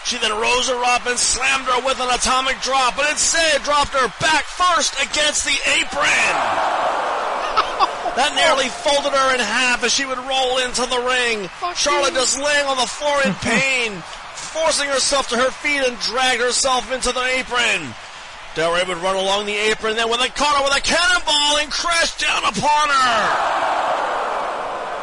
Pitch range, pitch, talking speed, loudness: 245-290 Hz, 260 Hz, 175 wpm, -17 LUFS